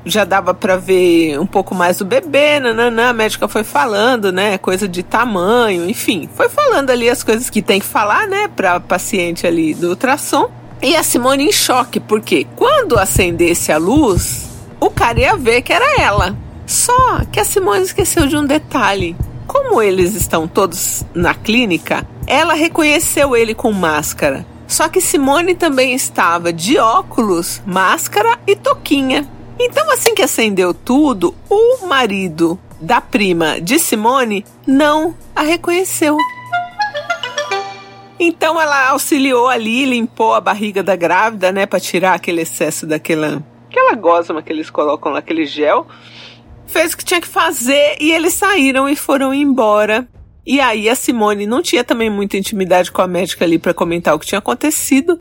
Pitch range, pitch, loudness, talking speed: 190-315 Hz, 245 Hz, -13 LUFS, 160 wpm